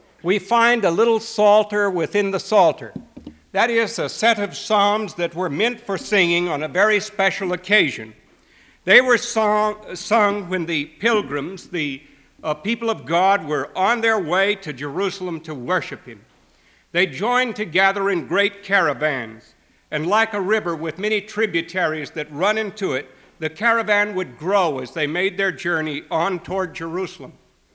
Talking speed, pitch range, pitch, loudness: 160 wpm, 165-210 Hz, 195 Hz, -20 LUFS